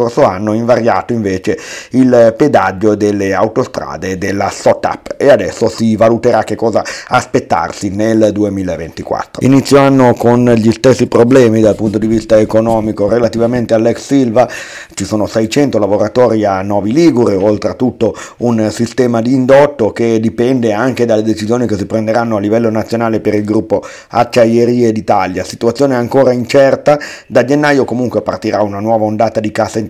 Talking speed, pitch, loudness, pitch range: 145 wpm, 115 Hz, -11 LUFS, 105-120 Hz